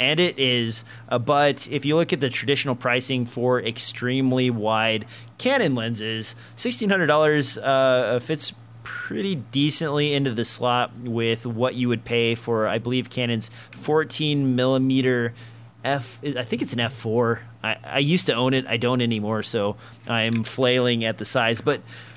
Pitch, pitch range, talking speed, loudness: 125 Hz, 115-135 Hz, 165 wpm, -23 LUFS